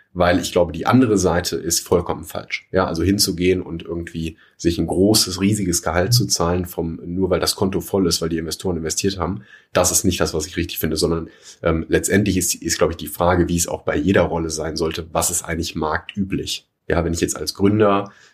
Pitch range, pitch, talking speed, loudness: 85-95 Hz, 85 Hz, 225 wpm, -20 LUFS